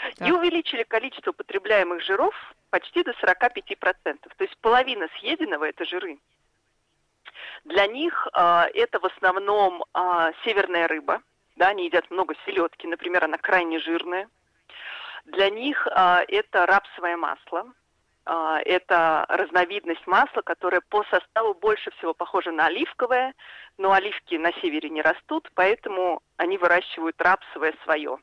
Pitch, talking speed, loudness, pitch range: 190 Hz, 130 wpm, -23 LUFS, 170-255 Hz